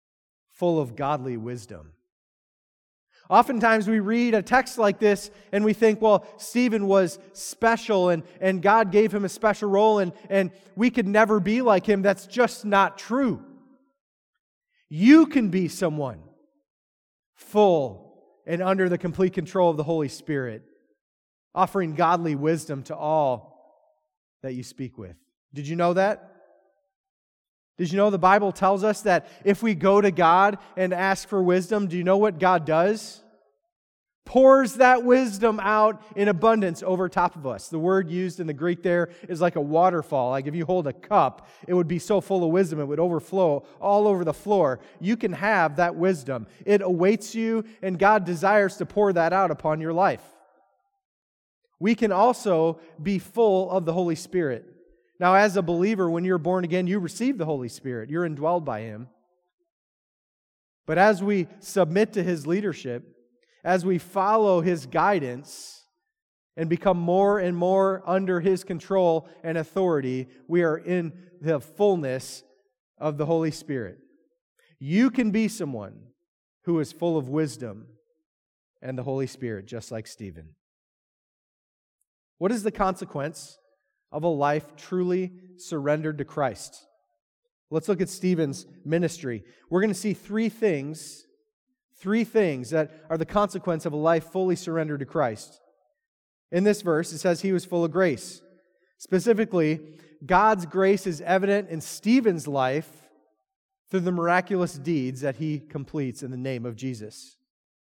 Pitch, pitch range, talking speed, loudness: 180 Hz, 155-205 Hz, 160 wpm, -24 LUFS